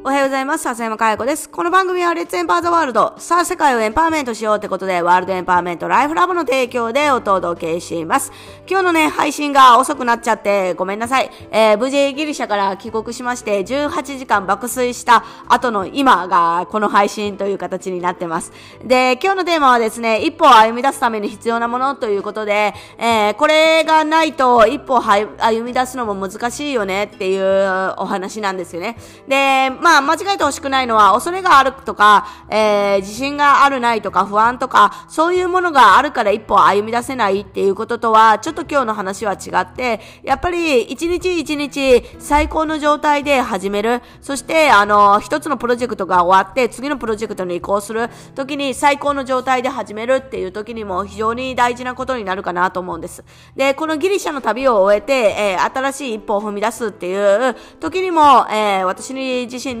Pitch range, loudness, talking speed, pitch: 205-280 Hz, -16 LUFS, 415 characters per minute, 240 Hz